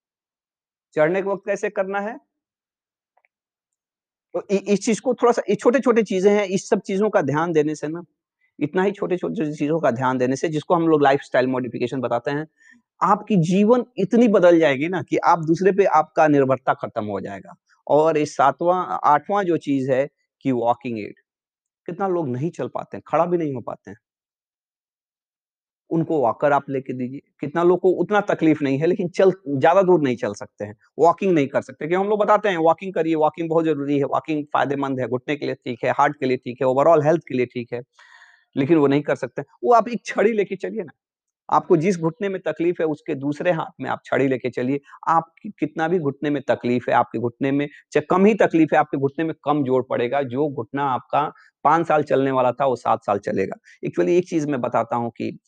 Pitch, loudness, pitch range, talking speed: 160 Hz, -21 LUFS, 140-195 Hz, 215 wpm